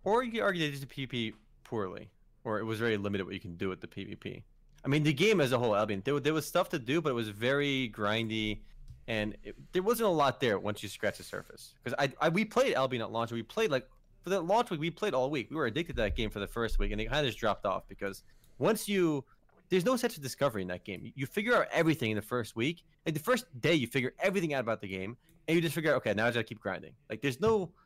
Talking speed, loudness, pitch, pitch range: 285 wpm, -32 LUFS, 130 Hz, 110-165 Hz